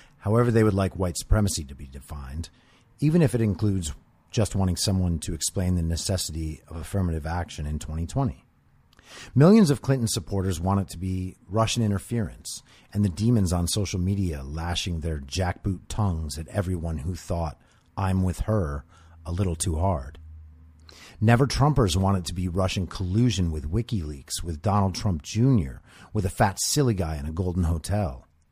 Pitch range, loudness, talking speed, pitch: 80-105 Hz, -26 LUFS, 165 wpm, 95 Hz